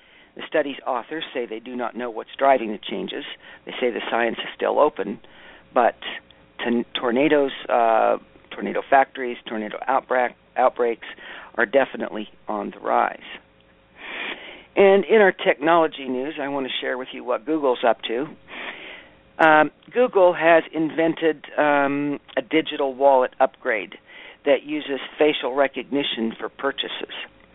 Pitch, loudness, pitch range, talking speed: 140 Hz, -22 LUFS, 120-155 Hz, 135 wpm